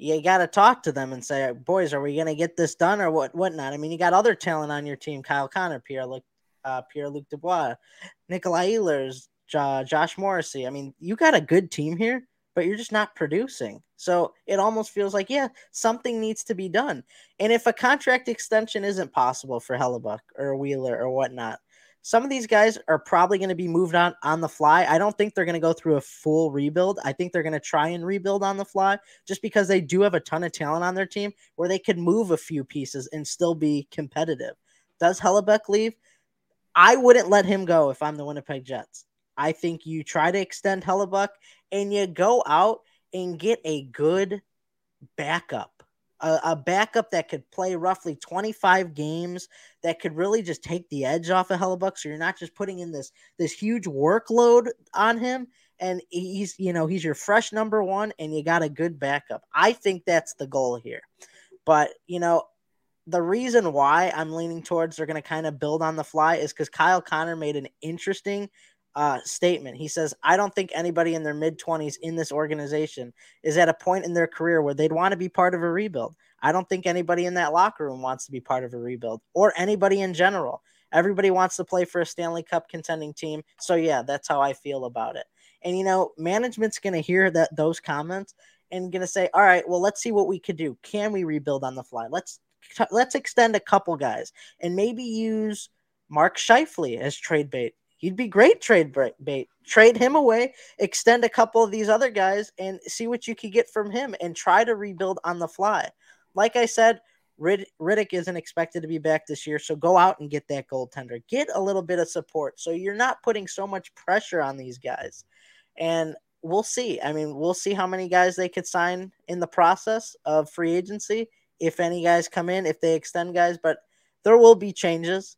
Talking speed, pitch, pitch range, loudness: 215 wpm, 175 Hz, 155-200 Hz, -24 LUFS